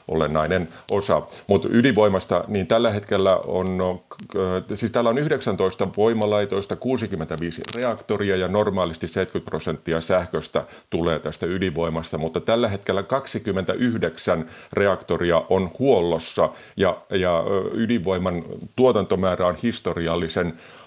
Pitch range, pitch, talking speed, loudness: 90-110 Hz, 95 Hz, 105 wpm, -23 LUFS